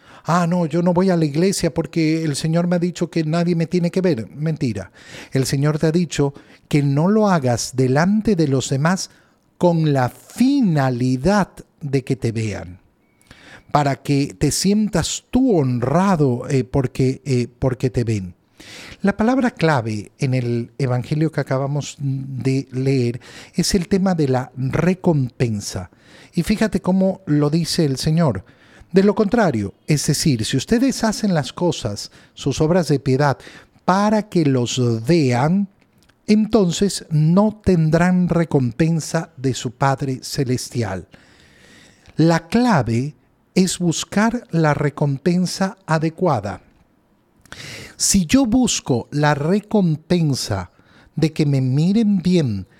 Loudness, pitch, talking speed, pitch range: -19 LUFS, 155 Hz, 135 wpm, 130-180 Hz